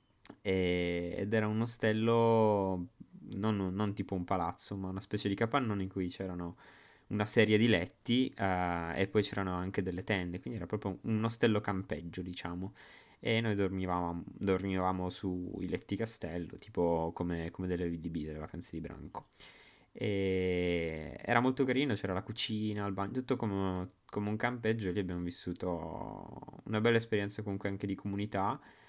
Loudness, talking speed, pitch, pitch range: -34 LUFS, 160 wpm, 95 Hz, 90-110 Hz